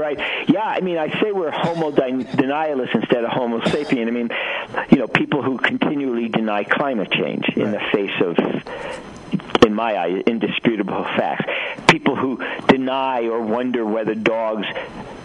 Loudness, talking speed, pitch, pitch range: -20 LUFS, 155 wpm, 120 Hz, 110-135 Hz